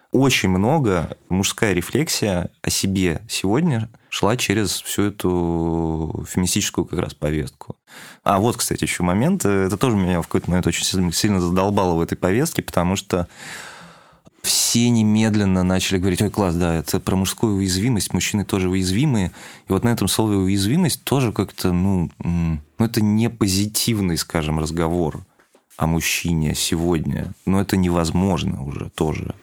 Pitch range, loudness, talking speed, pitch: 85-105 Hz, -20 LUFS, 145 wpm, 95 Hz